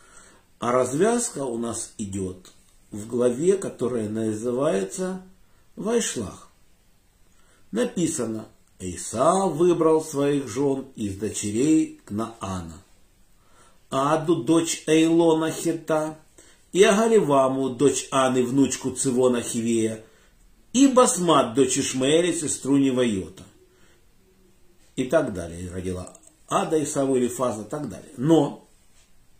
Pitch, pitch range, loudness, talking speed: 130 Hz, 105-160 Hz, -23 LUFS, 95 wpm